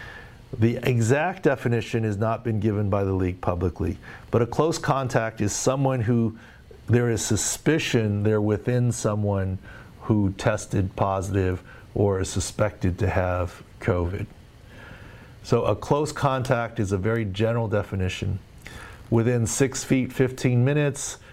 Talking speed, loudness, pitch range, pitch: 130 wpm, -24 LUFS, 100-125 Hz, 110 Hz